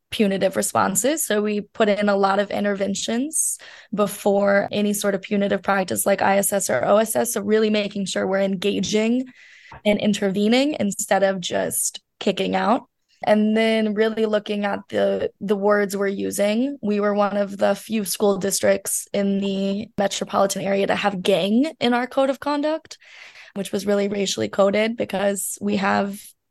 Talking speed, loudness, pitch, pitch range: 160 wpm, -21 LUFS, 205 Hz, 195-215 Hz